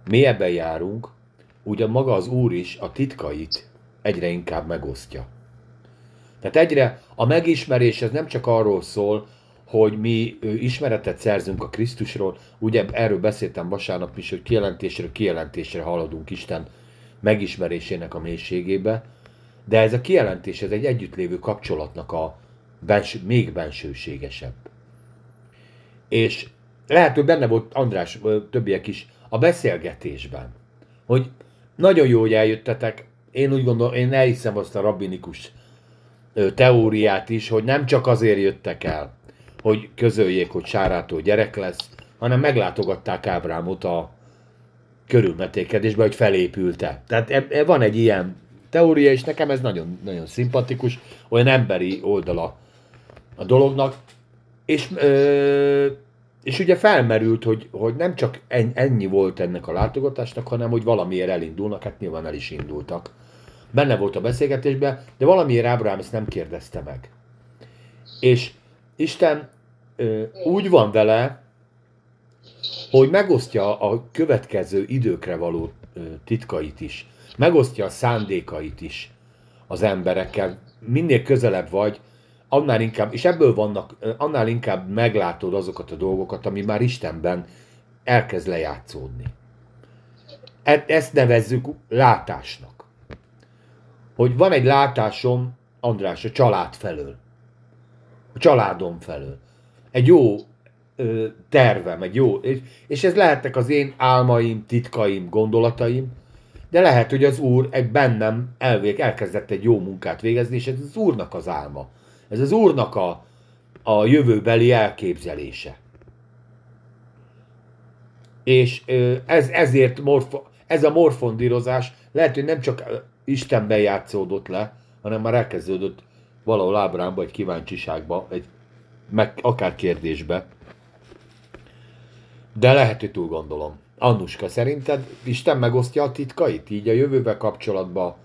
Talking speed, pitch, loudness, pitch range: 120 wpm, 120 Hz, -20 LUFS, 105-125 Hz